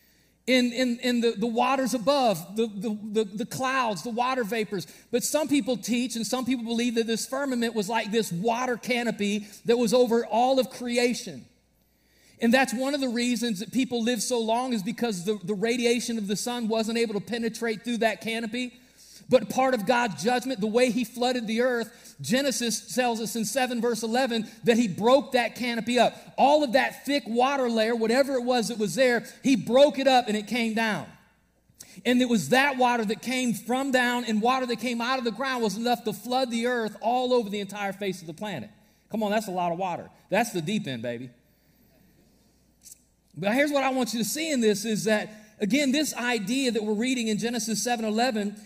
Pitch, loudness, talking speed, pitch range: 235 Hz, -26 LUFS, 210 wpm, 220-250 Hz